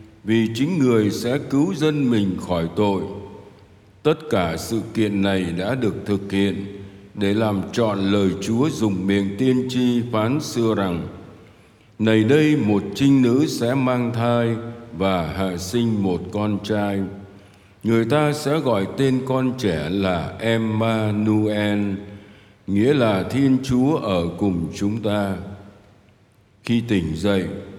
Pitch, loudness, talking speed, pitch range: 105 Hz, -21 LUFS, 140 wpm, 100-115 Hz